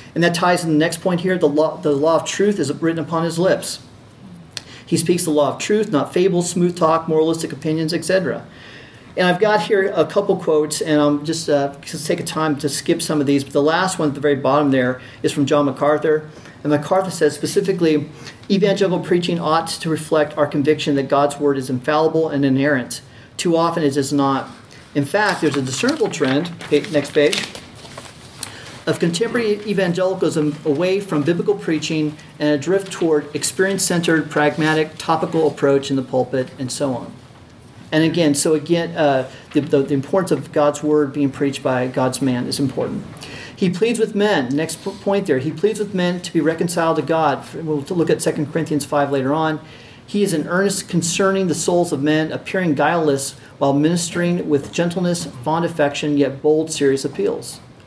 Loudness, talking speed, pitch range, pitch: -19 LUFS, 190 wpm, 145-175 Hz, 155 Hz